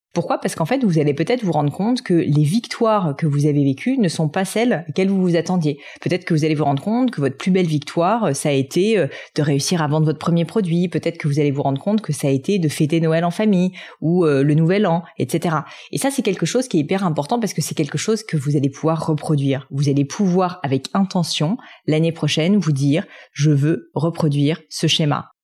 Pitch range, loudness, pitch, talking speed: 150-190 Hz, -19 LUFS, 165 Hz, 240 wpm